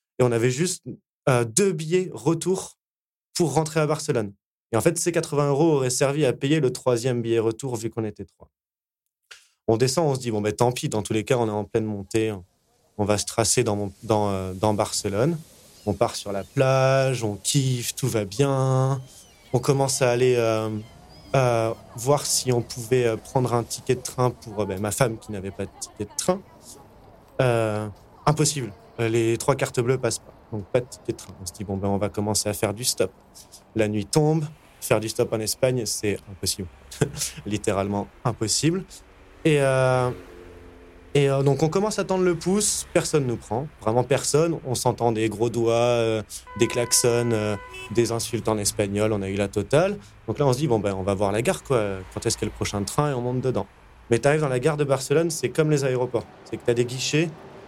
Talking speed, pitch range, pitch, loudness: 220 wpm, 105-135 Hz, 120 Hz, -24 LUFS